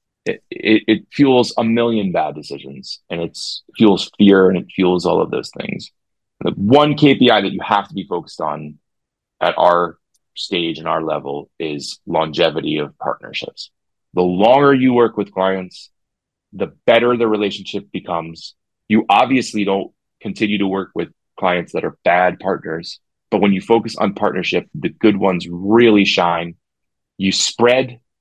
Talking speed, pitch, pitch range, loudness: 160 wpm, 95 Hz, 85-115 Hz, -17 LUFS